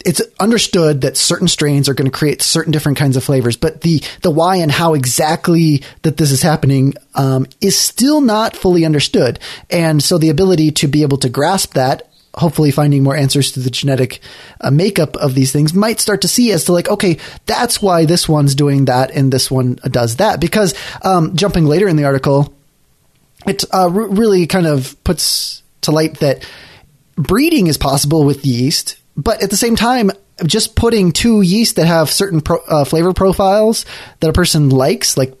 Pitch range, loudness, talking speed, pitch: 140-190 Hz, -13 LUFS, 195 wpm, 160 Hz